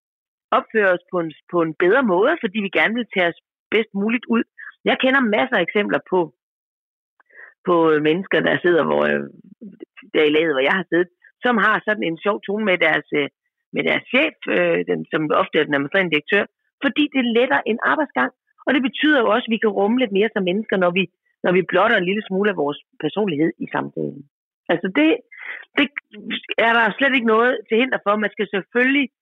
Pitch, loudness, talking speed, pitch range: 205 Hz, -19 LUFS, 205 wpm, 175-230 Hz